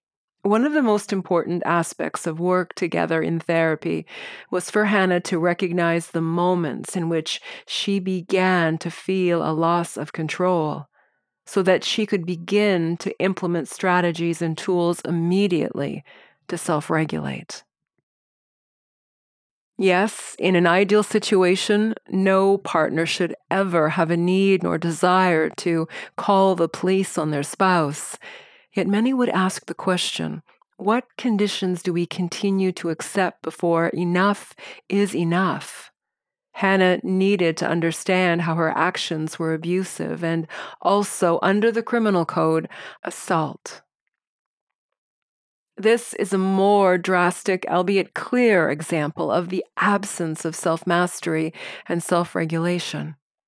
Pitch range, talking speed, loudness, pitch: 170-195 Hz, 125 wpm, -22 LUFS, 180 Hz